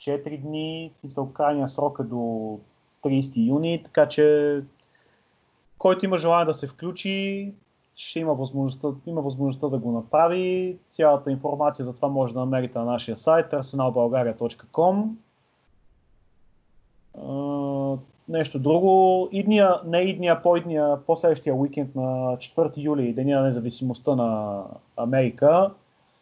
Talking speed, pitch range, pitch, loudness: 125 wpm, 130-165 Hz, 145 Hz, -24 LUFS